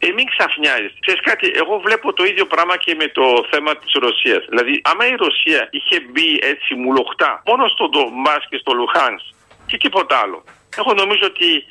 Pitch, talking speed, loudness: 200 Hz, 185 wpm, -15 LUFS